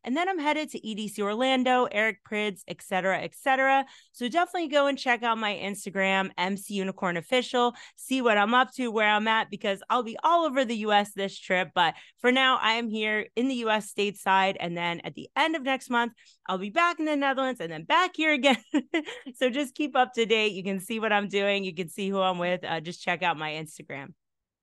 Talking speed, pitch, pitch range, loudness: 230 wpm, 220 Hz, 195-260 Hz, -26 LUFS